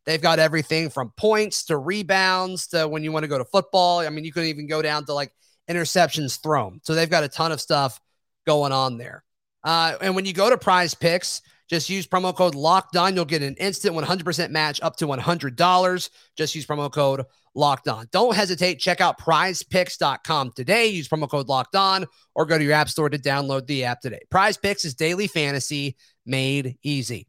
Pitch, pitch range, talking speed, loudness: 160 Hz, 145-180 Hz, 205 wpm, -22 LUFS